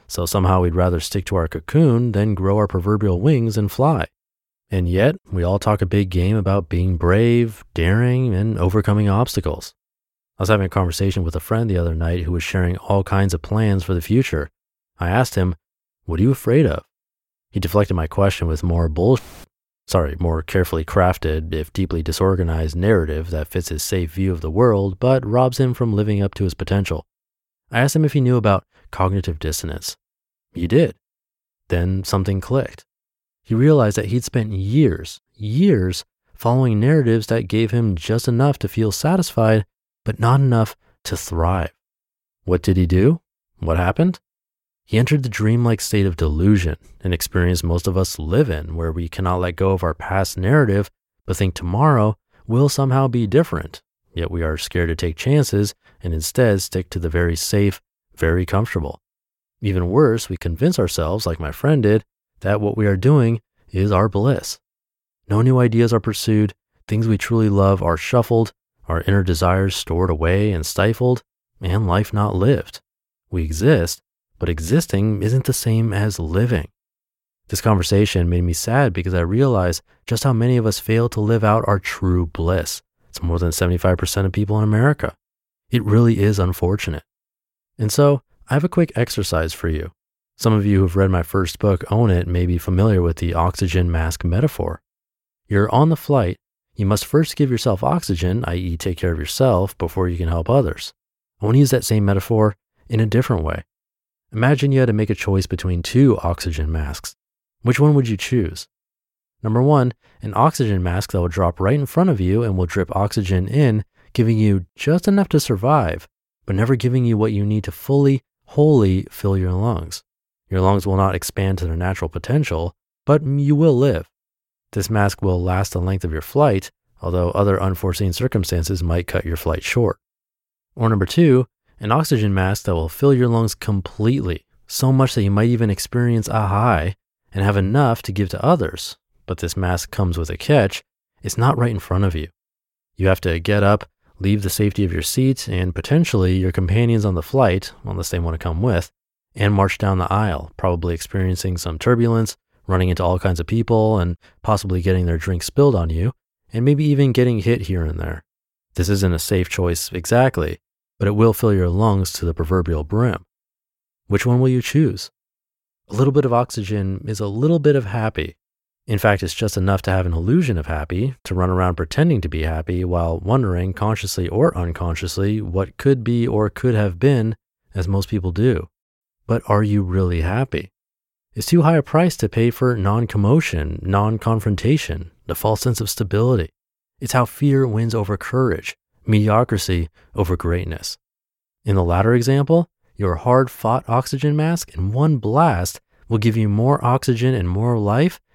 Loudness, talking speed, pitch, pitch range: -19 LUFS, 185 wpm, 100 Hz, 90-115 Hz